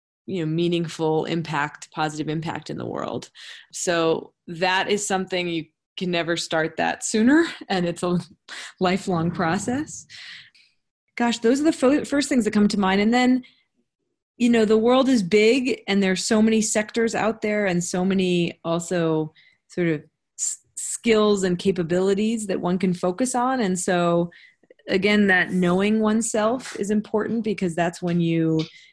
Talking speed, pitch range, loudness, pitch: 160 wpm, 170-220 Hz, -22 LUFS, 190 Hz